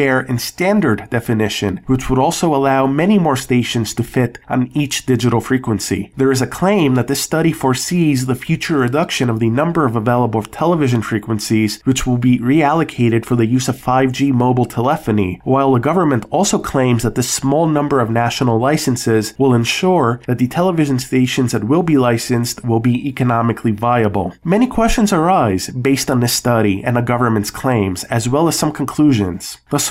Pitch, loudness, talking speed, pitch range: 125 Hz, -15 LUFS, 175 wpm, 115-145 Hz